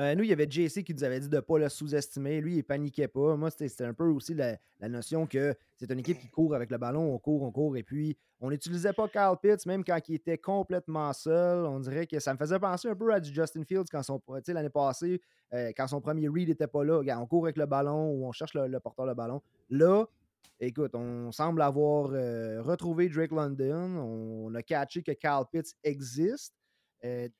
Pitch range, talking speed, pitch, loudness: 135-165 Hz, 240 wpm, 150 Hz, -31 LUFS